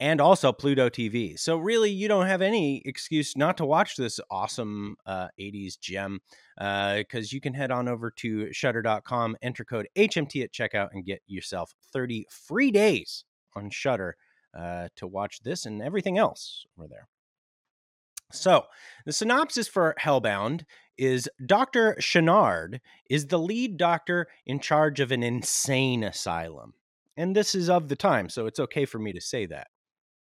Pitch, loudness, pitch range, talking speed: 130 Hz, -26 LUFS, 110-175 Hz, 165 wpm